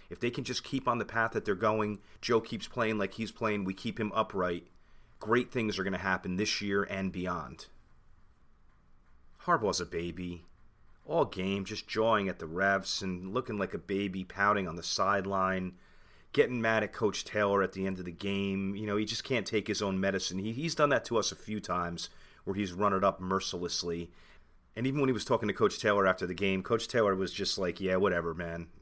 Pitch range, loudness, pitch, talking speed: 90-110 Hz, -32 LUFS, 100 Hz, 220 wpm